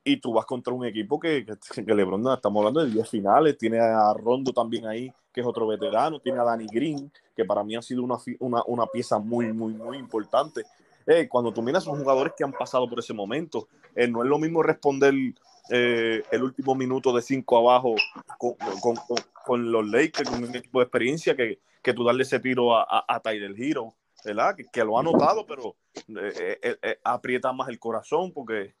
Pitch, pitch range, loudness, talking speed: 125 Hz, 115-135 Hz, -25 LUFS, 215 wpm